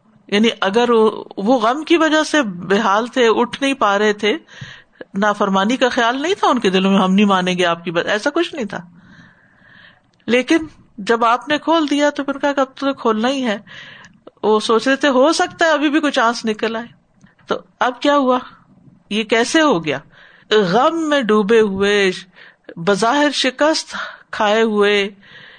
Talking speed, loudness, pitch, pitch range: 185 wpm, -16 LUFS, 230 Hz, 205-280 Hz